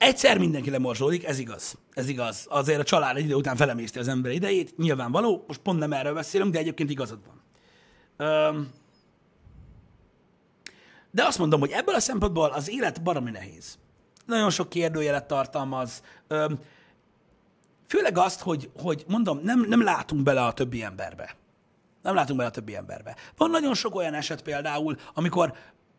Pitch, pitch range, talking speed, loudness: 150 Hz, 135-175 Hz, 155 wpm, -26 LUFS